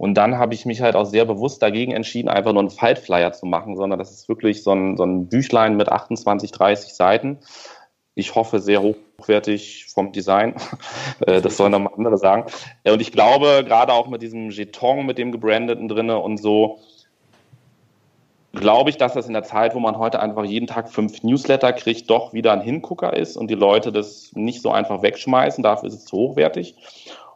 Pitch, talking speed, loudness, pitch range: 110 Hz, 195 wpm, -19 LUFS, 105-115 Hz